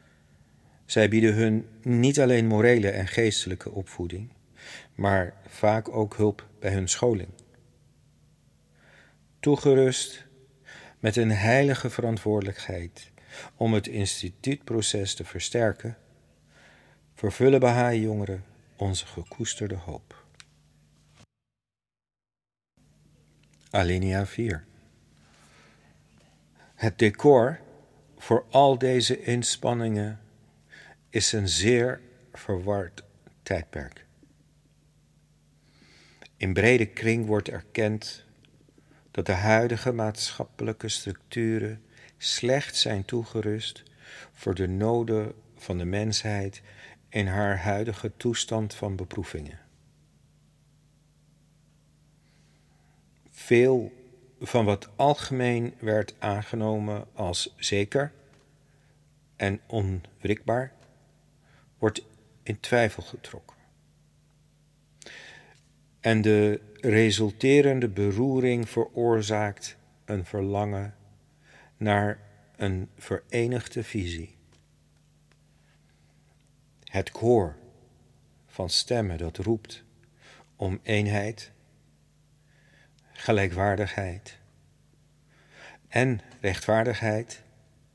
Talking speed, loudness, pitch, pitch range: 70 wpm, -26 LUFS, 110 Hz, 100-125 Hz